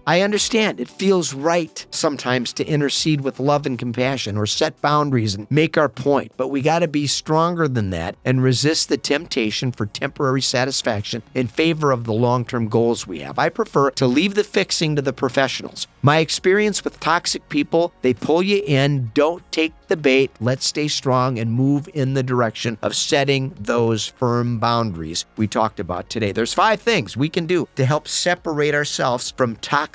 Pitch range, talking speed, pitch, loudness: 120-160 Hz, 185 wpm, 135 Hz, -20 LUFS